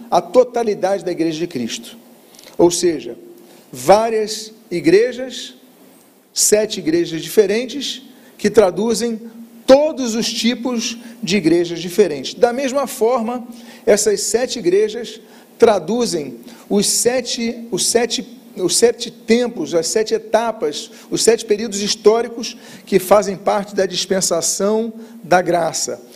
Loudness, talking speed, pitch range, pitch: -17 LUFS, 110 wpm, 200-240 Hz, 225 Hz